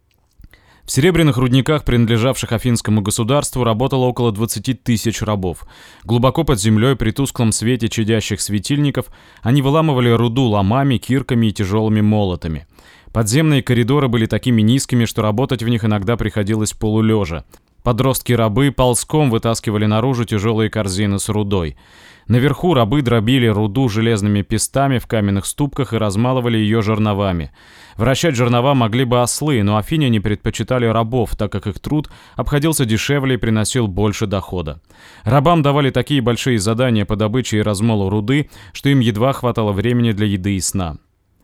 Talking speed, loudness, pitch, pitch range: 145 wpm, -17 LUFS, 115 Hz, 105-130 Hz